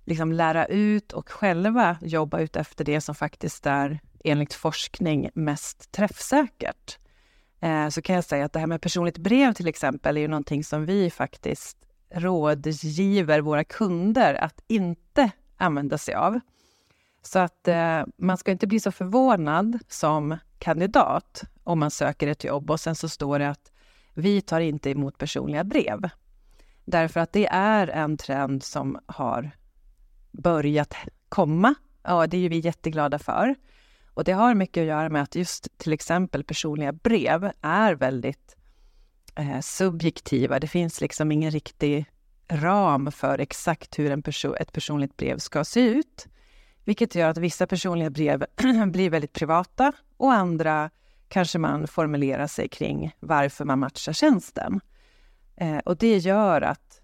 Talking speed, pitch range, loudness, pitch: 155 wpm, 150-195 Hz, -25 LUFS, 165 Hz